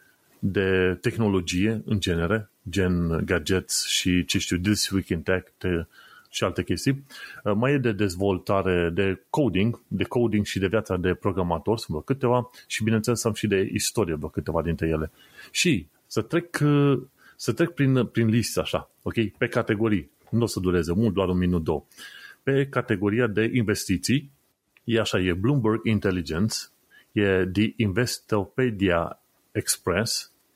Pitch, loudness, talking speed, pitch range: 105 Hz, -25 LUFS, 145 wpm, 90-115 Hz